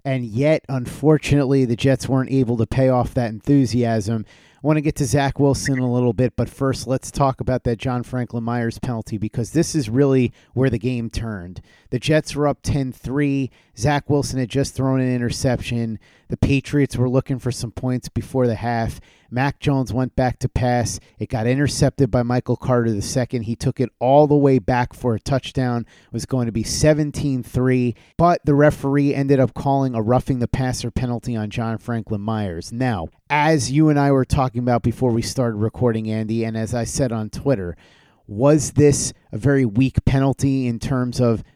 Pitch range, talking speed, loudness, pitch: 115-135 Hz, 200 wpm, -20 LUFS, 125 Hz